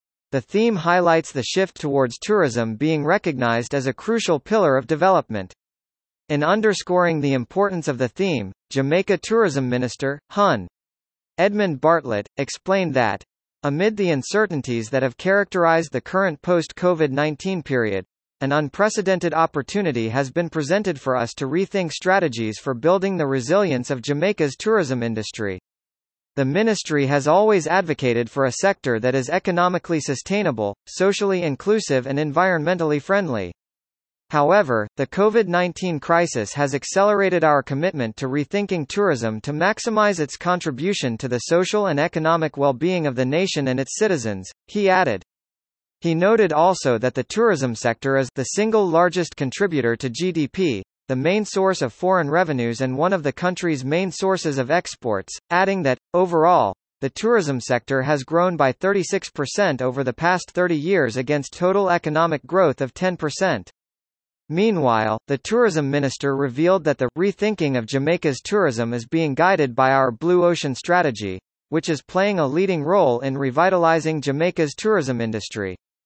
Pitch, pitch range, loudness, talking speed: 155 Hz, 130-185 Hz, -20 LUFS, 150 wpm